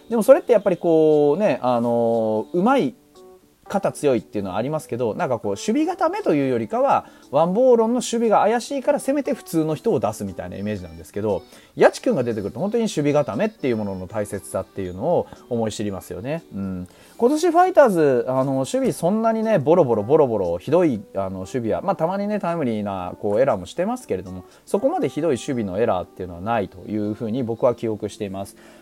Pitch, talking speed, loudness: 135 Hz, 475 characters per minute, -21 LUFS